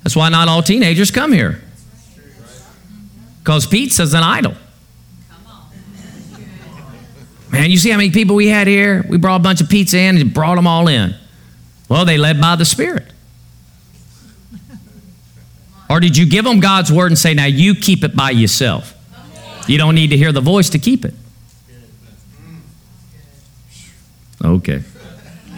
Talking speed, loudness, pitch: 150 wpm, -12 LUFS, 155 Hz